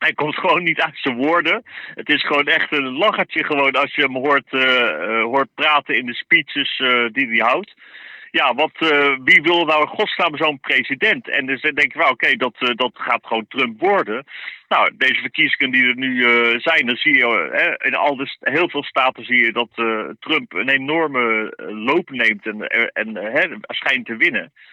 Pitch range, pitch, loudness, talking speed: 125-155 Hz, 140 Hz, -17 LUFS, 215 wpm